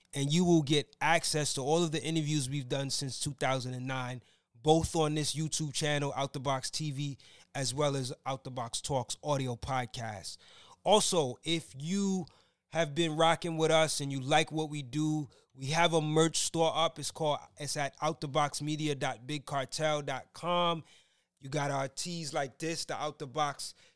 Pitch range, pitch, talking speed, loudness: 135-160 Hz, 150 Hz, 170 wpm, -32 LUFS